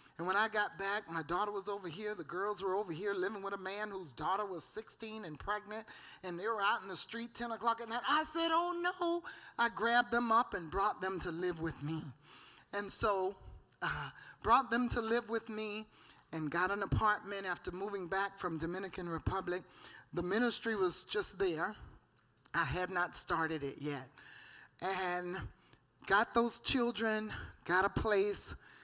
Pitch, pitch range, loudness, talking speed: 200 Hz, 180-230 Hz, -36 LUFS, 185 wpm